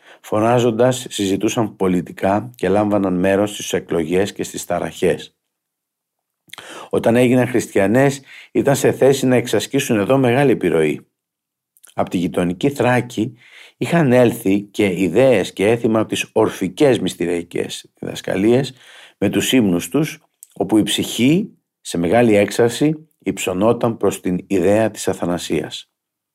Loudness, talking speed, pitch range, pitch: -17 LUFS, 120 wpm, 100-125 Hz, 110 Hz